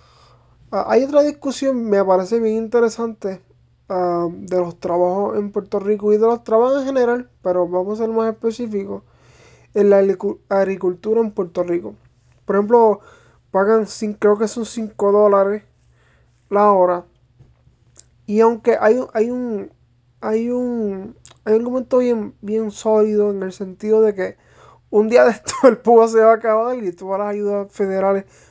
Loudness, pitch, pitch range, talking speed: -18 LUFS, 210 Hz, 190-225 Hz, 155 wpm